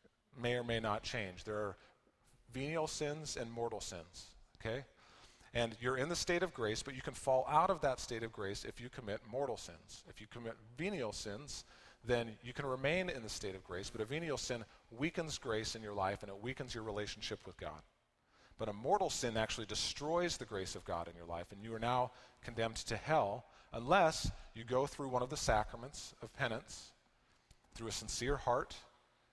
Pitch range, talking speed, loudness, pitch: 105-130 Hz, 205 wpm, -40 LUFS, 120 Hz